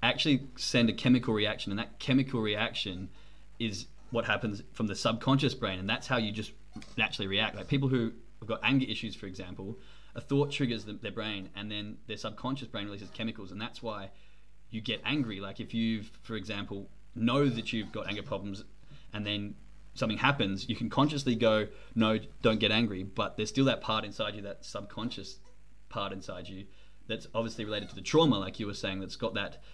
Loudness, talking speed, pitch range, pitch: -32 LUFS, 200 wpm, 100-120 Hz, 110 Hz